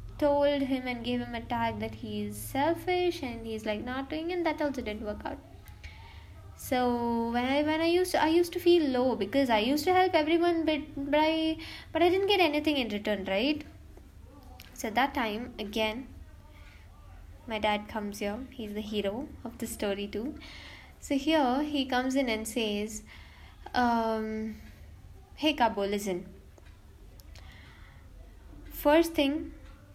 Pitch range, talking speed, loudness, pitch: 200-295 Hz, 160 wpm, -29 LUFS, 235 Hz